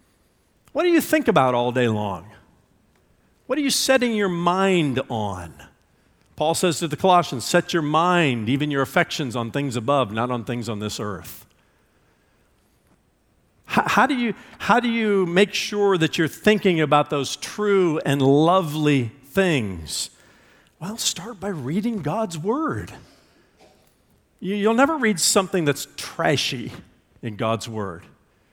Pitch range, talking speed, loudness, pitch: 125-205 Hz, 145 wpm, -21 LUFS, 160 Hz